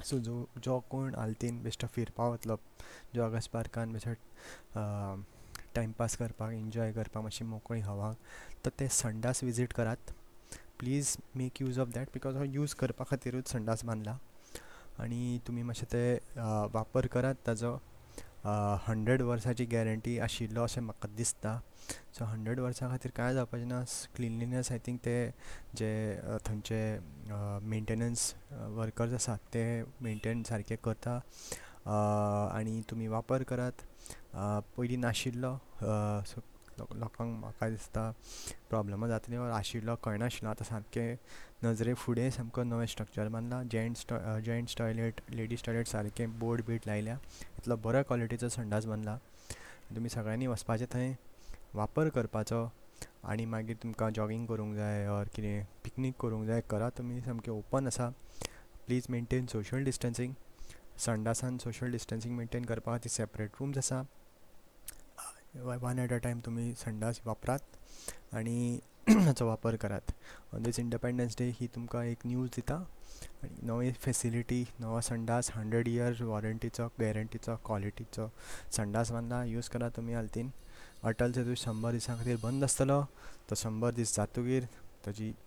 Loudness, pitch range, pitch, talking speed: -36 LUFS, 110-125 Hz, 115 Hz, 125 wpm